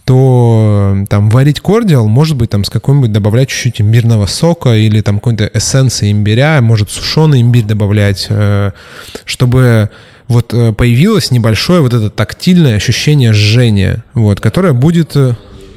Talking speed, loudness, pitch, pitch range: 130 wpm, -9 LUFS, 115 Hz, 105-130 Hz